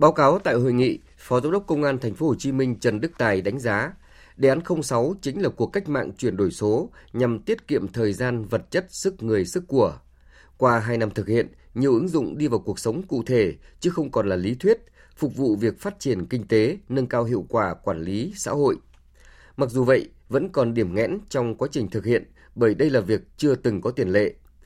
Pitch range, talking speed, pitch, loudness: 110-145 Hz, 240 wpm, 125 Hz, -24 LUFS